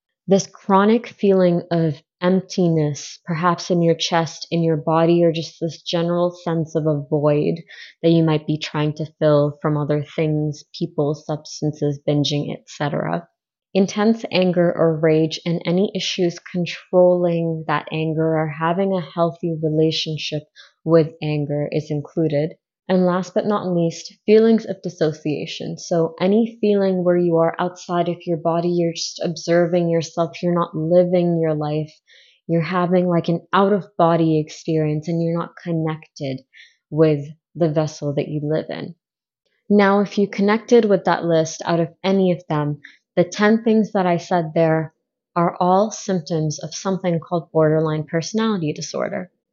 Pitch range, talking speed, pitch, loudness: 155-180 Hz, 155 wpm, 170 Hz, -20 LUFS